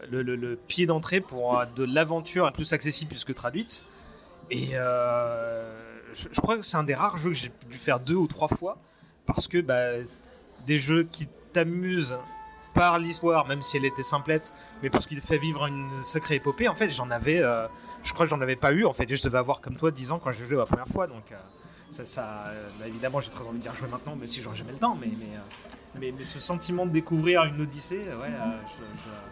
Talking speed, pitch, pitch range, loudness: 235 wpm, 140 Hz, 125-165 Hz, -27 LUFS